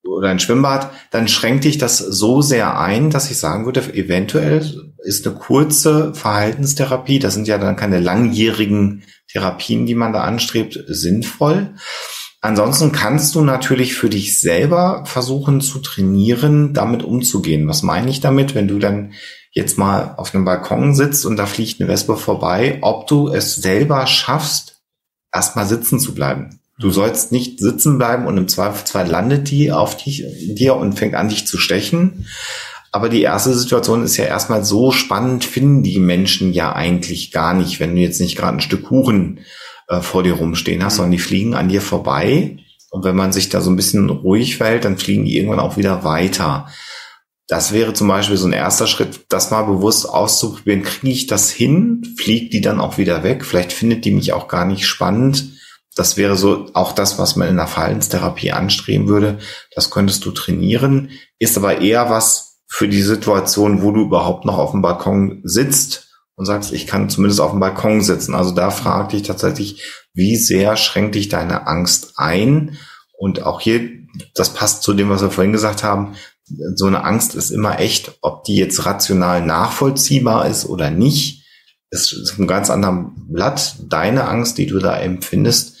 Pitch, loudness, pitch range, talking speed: 105 Hz, -15 LUFS, 95-130 Hz, 185 wpm